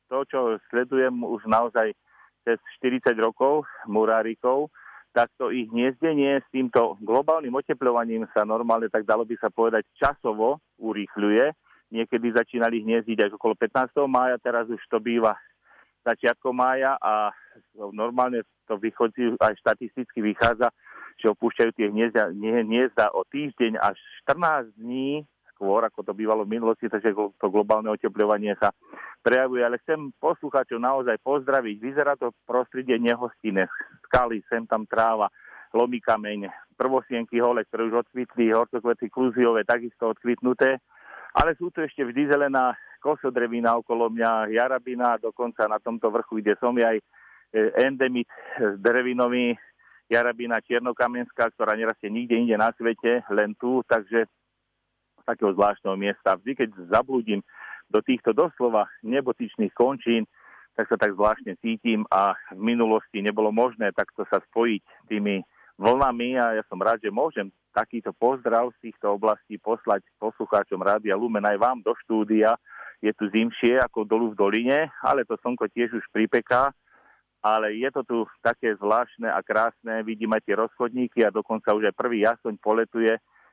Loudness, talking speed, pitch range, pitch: -24 LUFS, 145 wpm, 110-125 Hz, 115 Hz